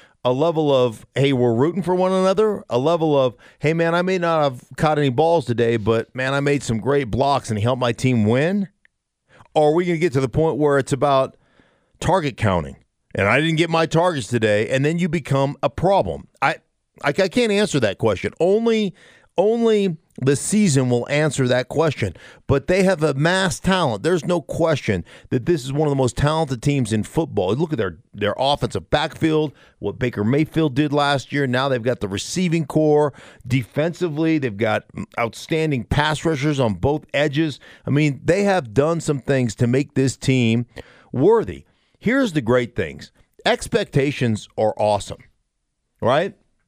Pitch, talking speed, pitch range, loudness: 145 Hz, 185 wpm, 125-165 Hz, -20 LUFS